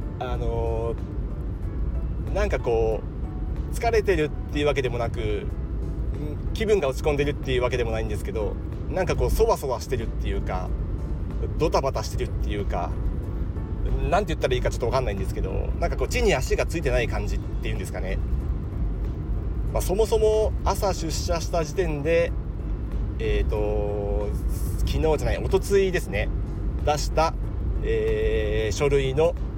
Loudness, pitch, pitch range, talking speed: -26 LUFS, 100 Hz, 80-125 Hz, 335 characters per minute